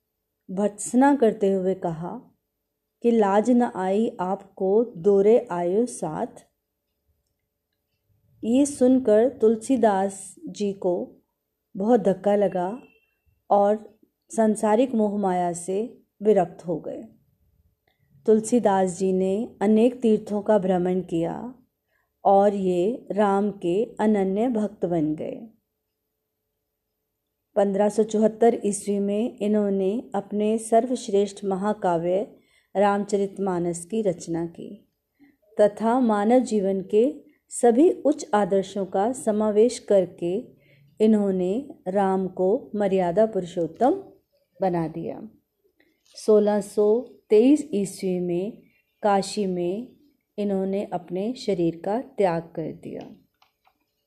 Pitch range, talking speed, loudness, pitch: 190-225 Hz, 95 wpm, -23 LUFS, 205 Hz